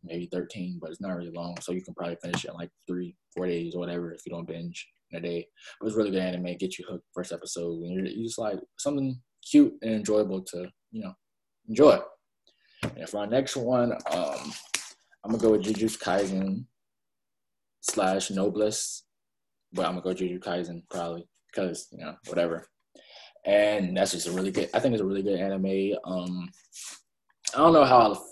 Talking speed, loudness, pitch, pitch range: 200 wpm, -28 LUFS, 95 Hz, 85-105 Hz